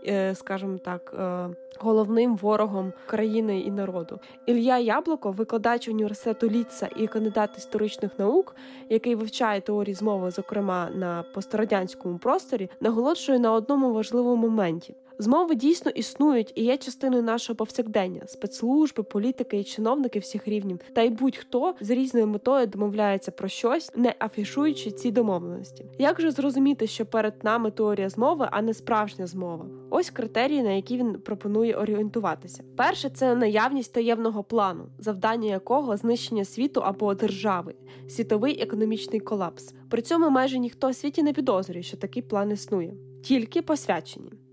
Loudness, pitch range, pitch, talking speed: -26 LUFS, 200-250 Hz, 220 Hz, 140 wpm